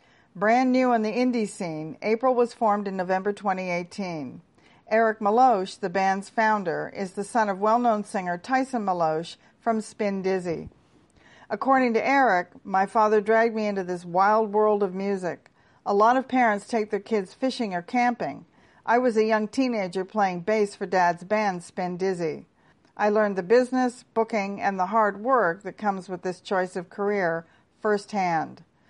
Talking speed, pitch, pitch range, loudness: 170 wpm, 205 Hz, 190-225 Hz, -25 LUFS